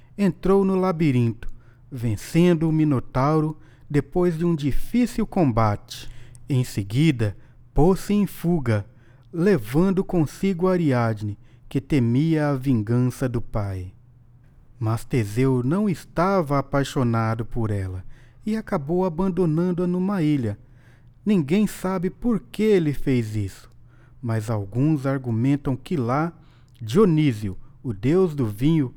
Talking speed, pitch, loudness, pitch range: 110 wpm, 135 Hz, -23 LUFS, 120-170 Hz